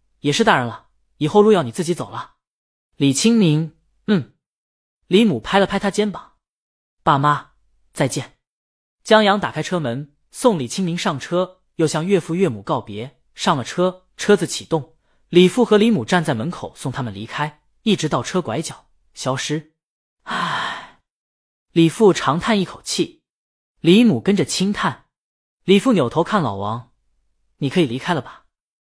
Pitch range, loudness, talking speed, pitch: 140-195 Hz, -19 LUFS, 225 characters per minute, 165 Hz